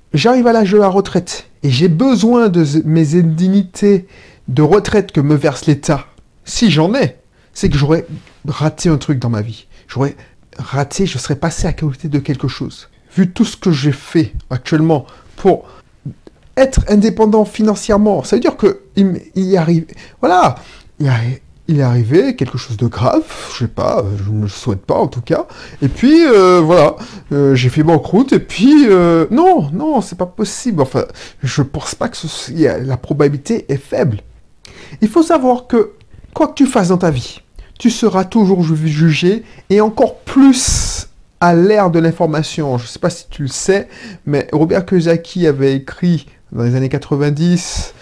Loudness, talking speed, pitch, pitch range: -13 LUFS, 180 wpm, 165 Hz, 140-200 Hz